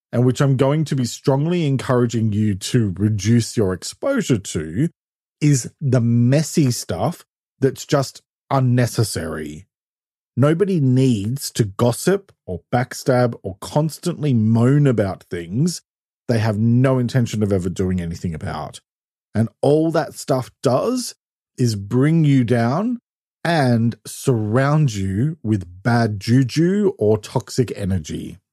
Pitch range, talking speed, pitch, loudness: 110-140 Hz, 125 wpm, 125 Hz, -19 LUFS